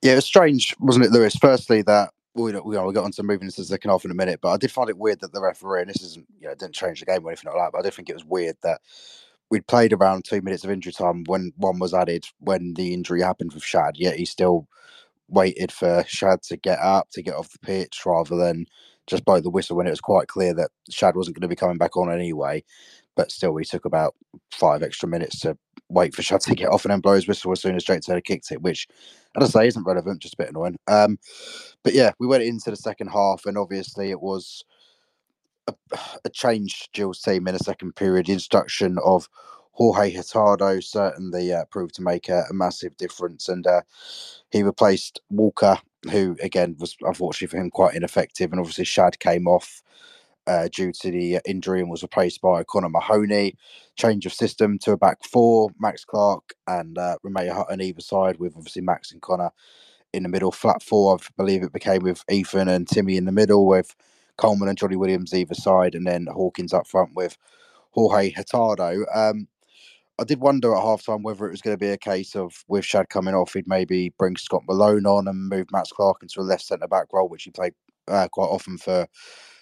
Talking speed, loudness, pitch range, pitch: 230 wpm, -22 LUFS, 90-105 Hz, 95 Hz